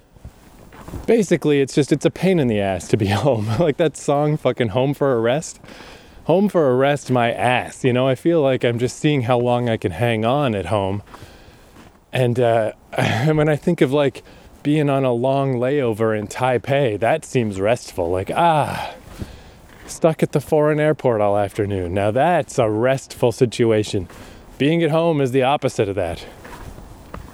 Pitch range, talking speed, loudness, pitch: 110-150 Hz, 180 wpm, -19 LUFS, 125 Hz